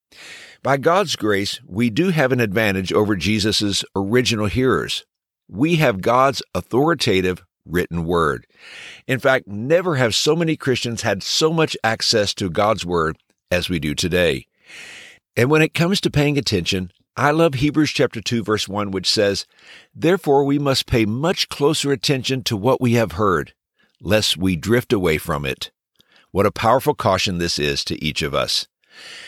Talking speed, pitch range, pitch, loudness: 165 wpm, 95-140 Hz, 110 Hz, -19 LUFS